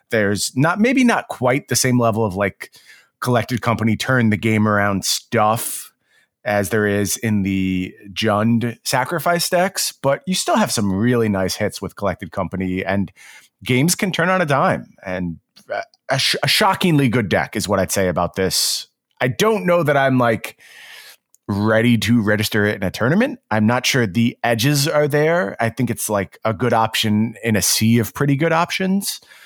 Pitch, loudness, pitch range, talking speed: 115 Hz, -18 LUFS, 100-140 Hz, 180 wpm